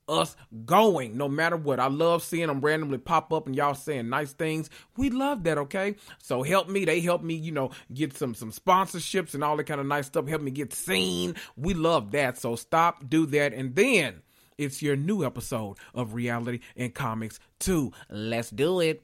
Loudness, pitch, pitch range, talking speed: -27 LUFS, 150 Hz, 125-165 Hz, 205 wpm